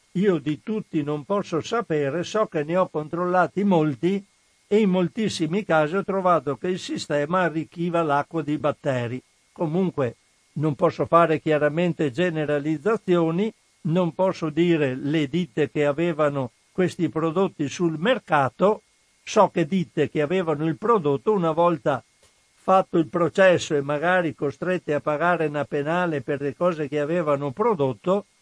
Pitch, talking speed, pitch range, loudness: 165 Hz, 140 wpm, 150-185 Hz, -23 LUFS